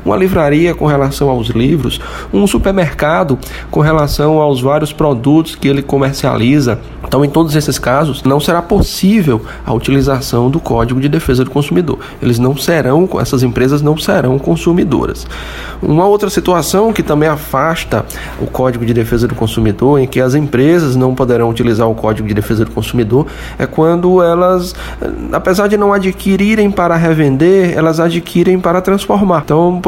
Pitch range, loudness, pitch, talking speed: 130-170 Hz, -12 LUFS, 145 Hz, 160 wpm